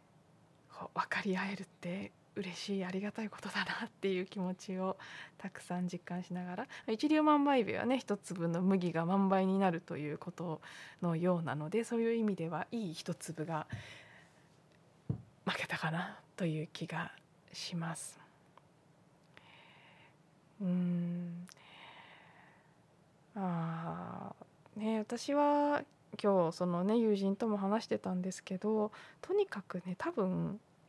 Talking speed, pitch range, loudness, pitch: 240 characters per minute, 165-200 Hz, -36 LUFS, 180 Hz